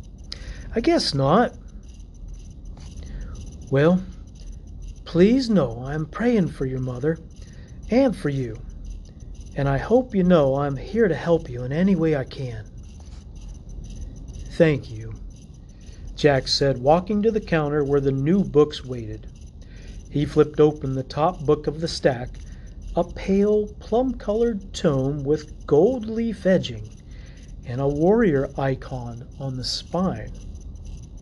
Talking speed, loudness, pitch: 130 wpm, -22 LUFS, 140 Hz